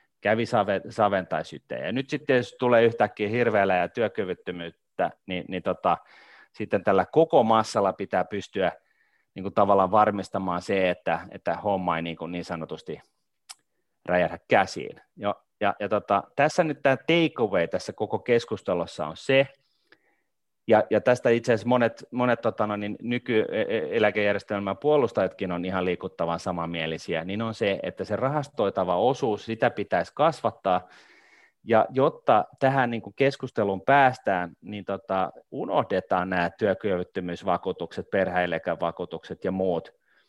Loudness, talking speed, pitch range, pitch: -25 LUFS, 130 wpm, 90-120 Hz, 105 Hz